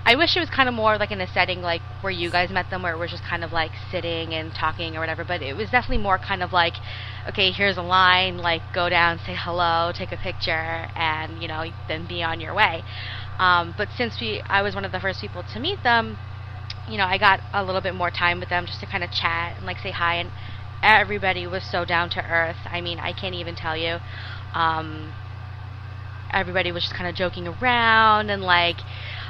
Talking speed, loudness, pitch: 235 wpm, -22 LUFS, 105 Hz